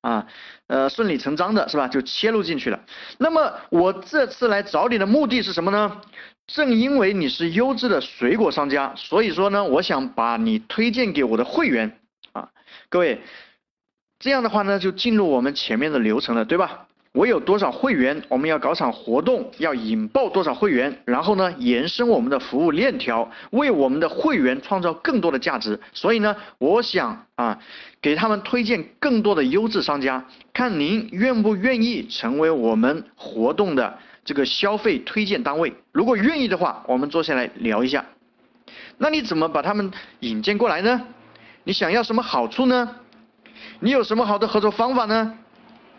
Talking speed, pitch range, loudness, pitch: 270 characters per minute, 190-245 Hz, -21 LUFS, 220 Hz